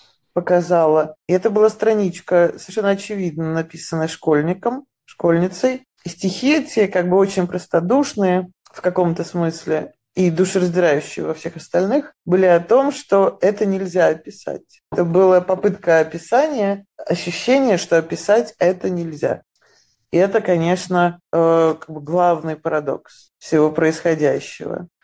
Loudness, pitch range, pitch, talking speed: -18 LUFS, 165-195 Hz, 180 Hz, 120 wpm